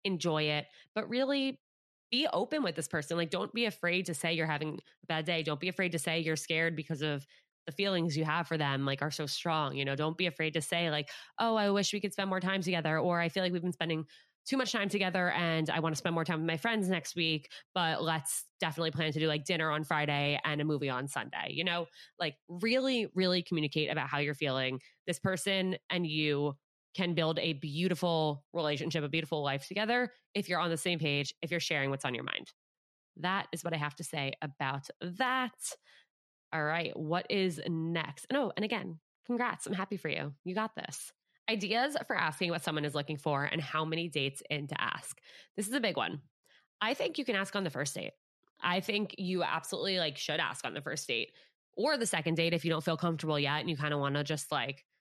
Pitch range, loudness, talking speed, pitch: 155-185 Hz, -33 LUFS, 235 wpm, 165 Hz